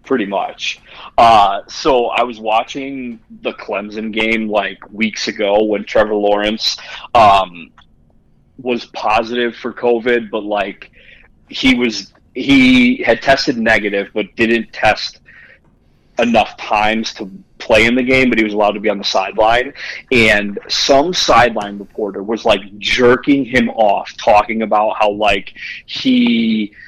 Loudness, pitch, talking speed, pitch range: -14 LUFS, 110 Hz, 140 wpm, 105-125 Hz